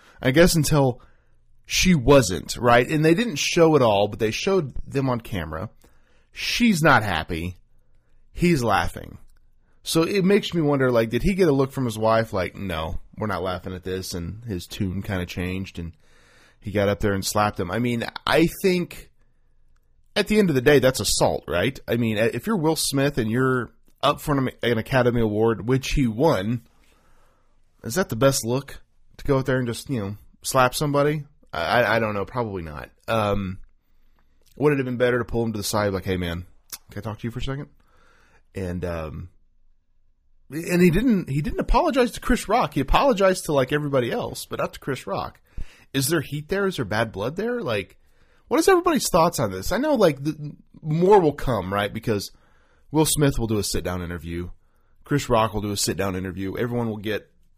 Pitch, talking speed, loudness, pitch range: 120 Hz, 205 wpm, -22 LUFS, 100-145 Hz